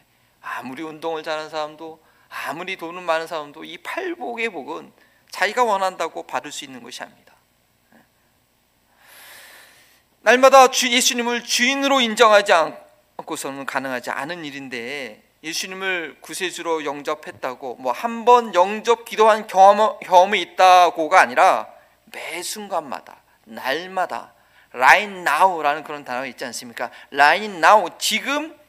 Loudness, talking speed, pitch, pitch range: -19 LUFS, 305 characters per minute, 180 Hz, 150-220 Hz